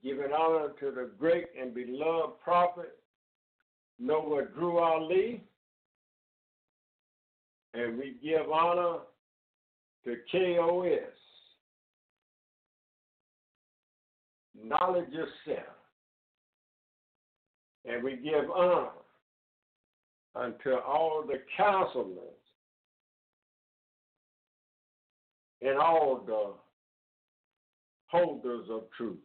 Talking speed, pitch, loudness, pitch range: 70 wpm, 145 Hz, -31 LUFS, 115-170 Hz